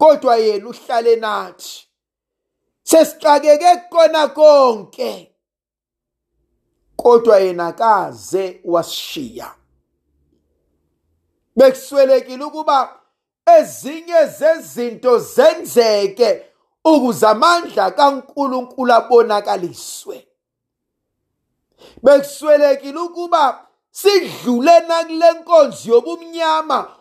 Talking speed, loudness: 60 wpm, -14 LUFS